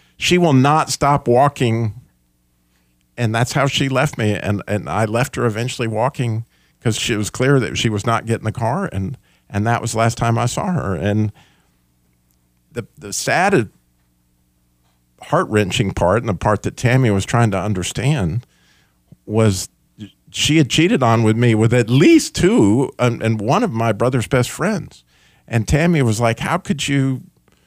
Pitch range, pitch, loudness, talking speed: 100-130 Hz, 115 Hz, -17 LUFS, 175 wpm